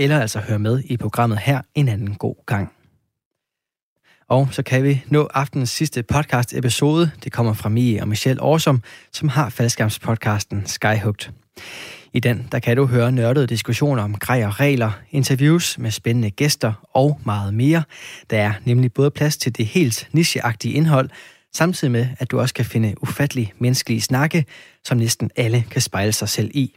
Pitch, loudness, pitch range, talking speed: 125 Hz, -19 LUFS, 115-140 Hz, 175 wpm